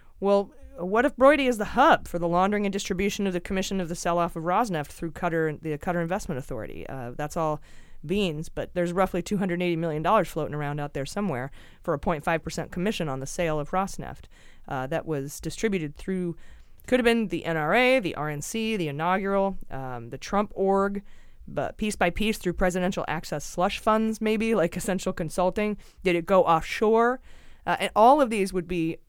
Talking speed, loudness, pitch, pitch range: 195 wpm, -26 LUFS, 180 Hz, 160-200 Hz